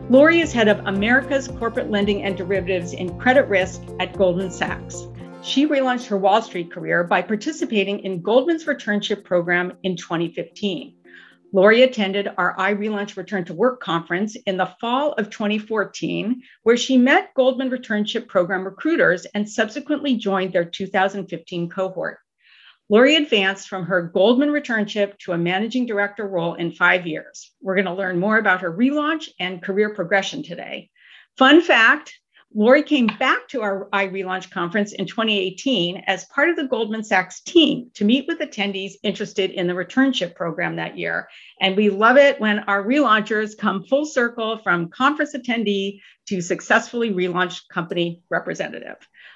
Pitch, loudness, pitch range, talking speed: 205 Hz, -20 LUFS, 185-250 Hz, 155 wpm